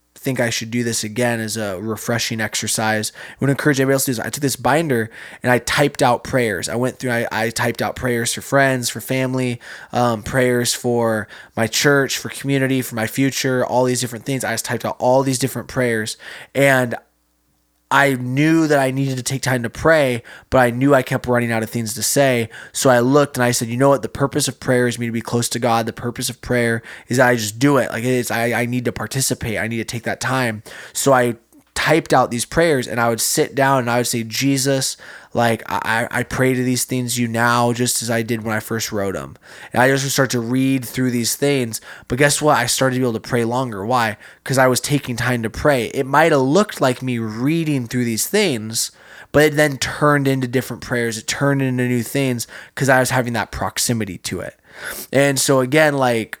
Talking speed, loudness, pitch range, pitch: 235 wpm, -18 LUFS, 115-135 Hz, 125 Hz